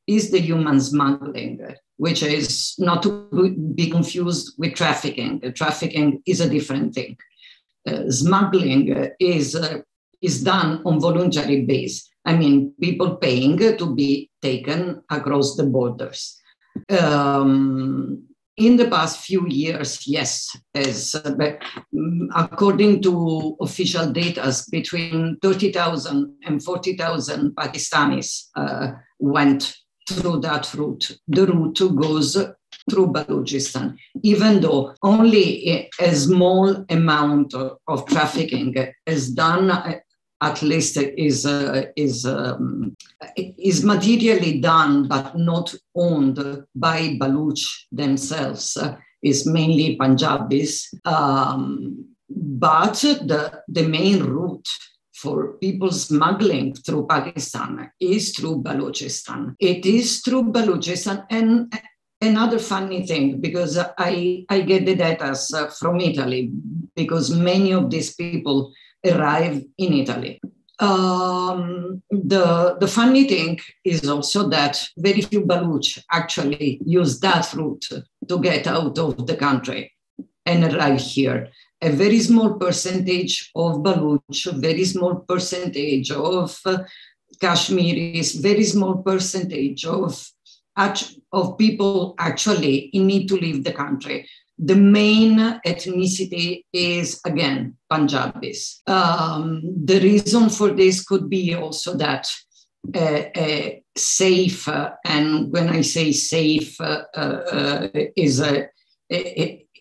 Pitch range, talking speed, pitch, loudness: 145-185 Hz, 115 wpm, 165 Hz, -20 LUFS